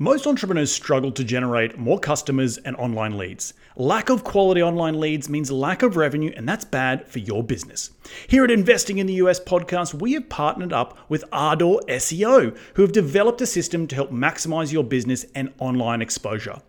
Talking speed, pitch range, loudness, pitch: 185 wpm, 130-195 Hz, -21 LUFS, 155 Hz